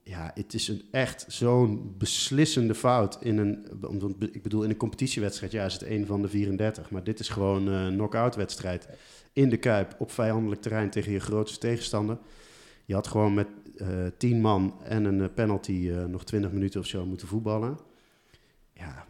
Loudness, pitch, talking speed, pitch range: -29 LUFS, 105 Hz, 180 wpm, 100-110 Hz